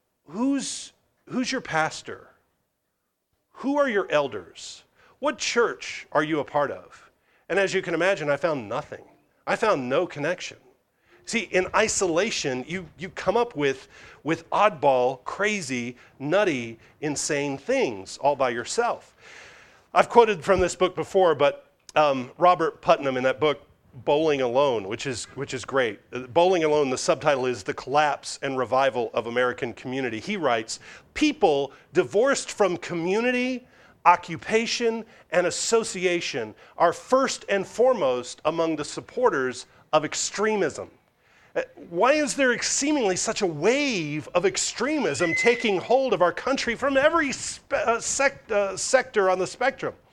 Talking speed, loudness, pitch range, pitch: 140 wpm, -24 LUFS, 145-235 Hz, 180 Hz